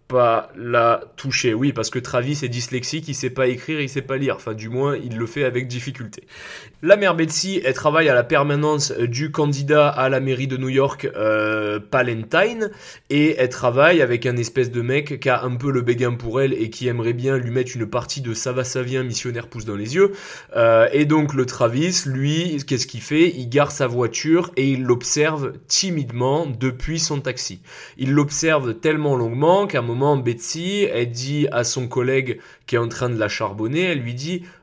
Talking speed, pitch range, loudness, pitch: 210 wpm, 120-150 Hz, -20 LUFS, 130 Hz